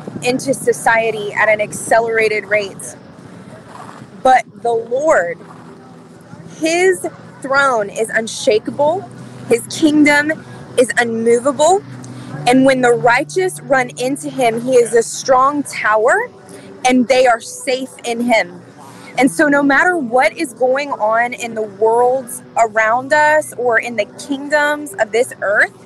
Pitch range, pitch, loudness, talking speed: 230-290 Hz, 255 Hz, -15 LUFS, 130 wpm